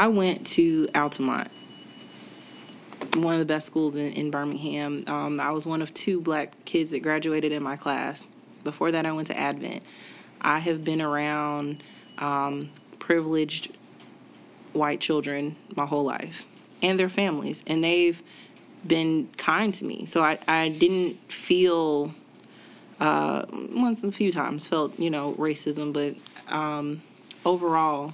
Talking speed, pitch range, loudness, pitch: 145 wpm, 145-170 Hz, -26 LUFS, 155 Hz